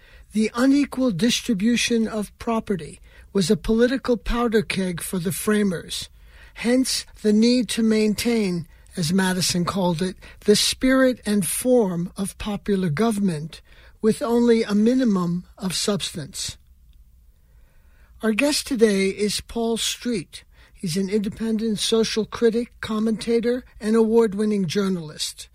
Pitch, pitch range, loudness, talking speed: 210 Hz, 185-230 Hz, -22 LUFS, 120 wpm